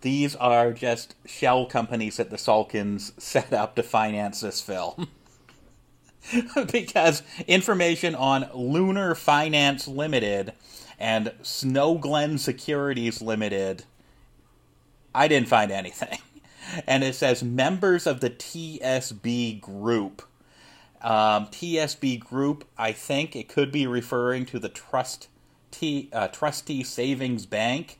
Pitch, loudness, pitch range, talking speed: 125 Hz, -25 LUFS, 110-150 Hz, 115 wpm